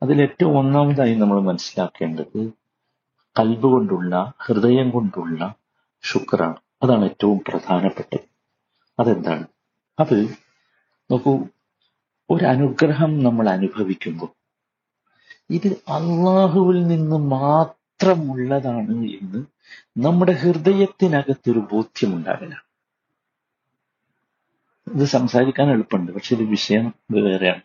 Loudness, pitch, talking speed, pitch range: -19 LUFS, 135 Hz, 80 wpm, 110-155 Hz